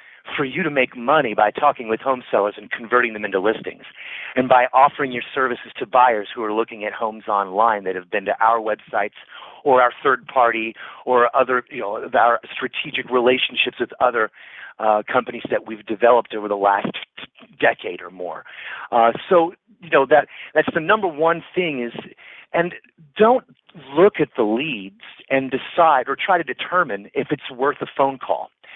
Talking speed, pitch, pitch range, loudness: 180 wpm, 125 Hz, 110-150 Hz, -20 LUFS